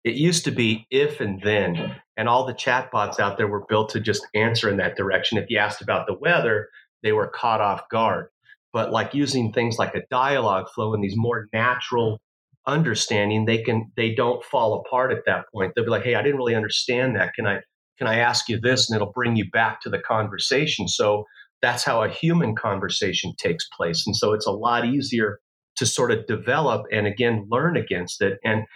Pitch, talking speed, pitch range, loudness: 115 Hz, 215 wpm, 110-125 Hz, -22 LUFS